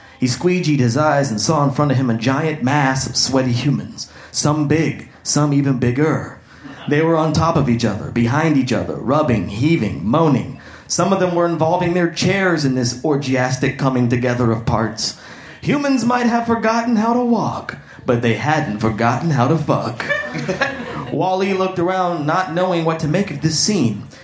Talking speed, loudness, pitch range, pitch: 180 wpm, -17 LUFS, 125-170 Hz, 150 Hz